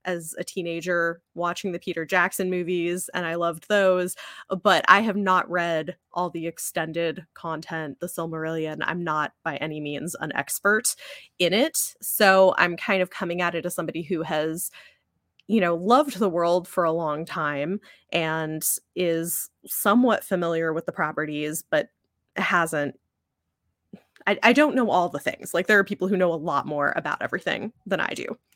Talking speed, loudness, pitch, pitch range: 170 wpm, -24 LUFS, 175 Hz, 165-190 Hz